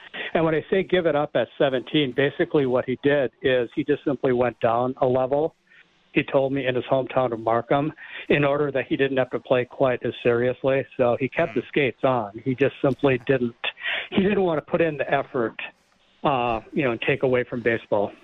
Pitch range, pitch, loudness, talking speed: 125-150 Hz, 135 Hz, -23 LUFS, 215 wpm